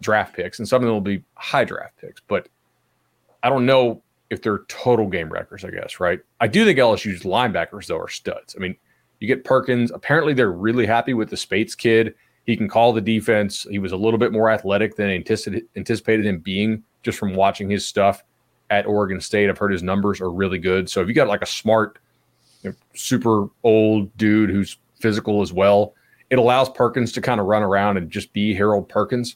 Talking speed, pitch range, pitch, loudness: 210 wpm, 100-115 Hz, 105 Hz, -20 LUFS